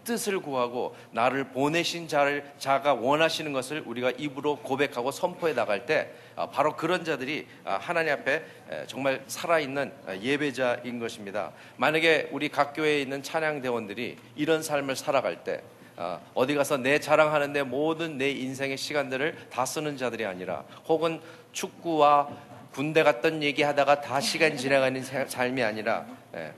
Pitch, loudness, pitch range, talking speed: 145 Hz, -27 LUFS, 130-155 Hz, 320 characters per minute